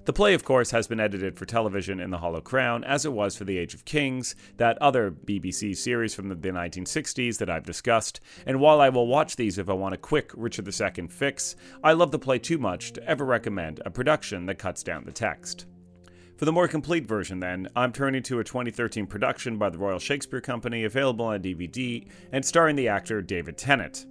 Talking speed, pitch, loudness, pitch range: 215 wpm, 115 Hz, -26 LUFS, 95-135 Hz